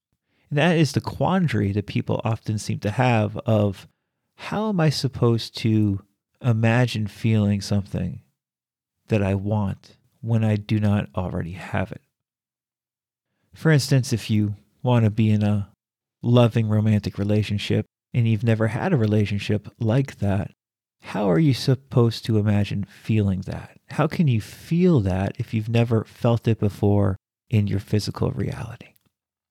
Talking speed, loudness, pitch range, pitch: 150 wpm, -23 LUFS, 105-120 Hz, 110 Hz